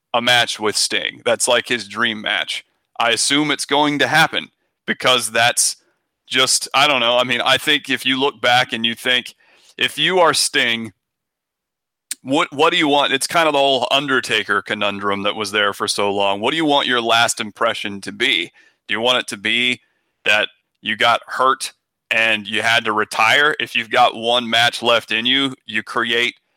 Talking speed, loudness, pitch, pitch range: 200 wpm, -16 LUFS, 120 Hz, 110-130 Hz